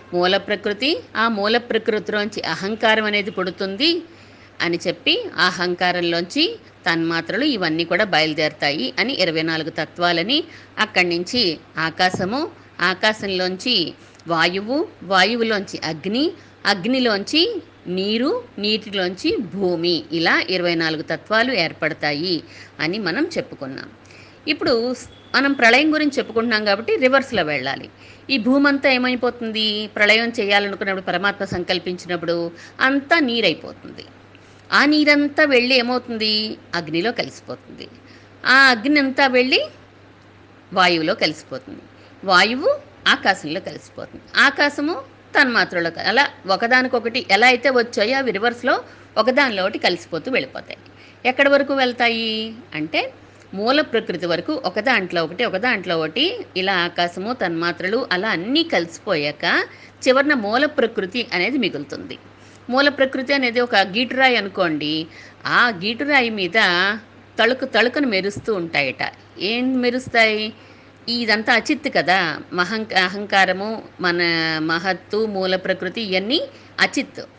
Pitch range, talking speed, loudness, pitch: 180-255 Hz, 105 wpm, -19 LUFS, 215 Hz